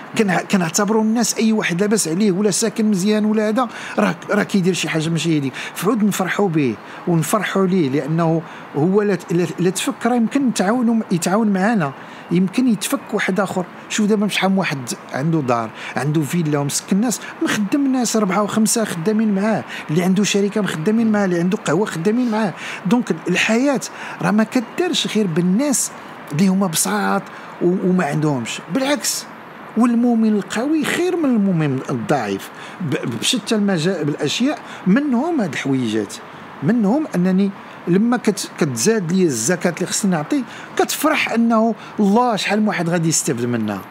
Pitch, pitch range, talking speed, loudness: 205 Hz, 175-225 Hz, 145 wpm, -18 LUFS